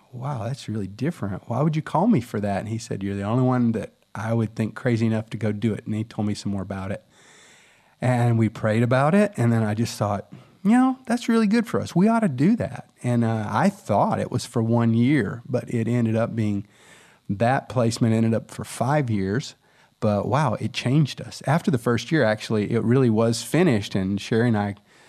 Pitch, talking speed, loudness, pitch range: 115 Hz, 230 wpm, -23 LUFS, 110-145 Hz